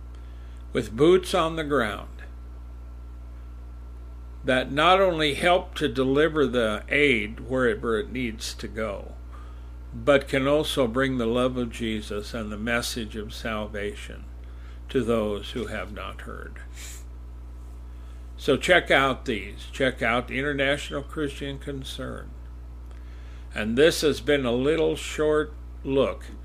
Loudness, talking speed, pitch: -25 LUFS, 120 wpm, 105 Hz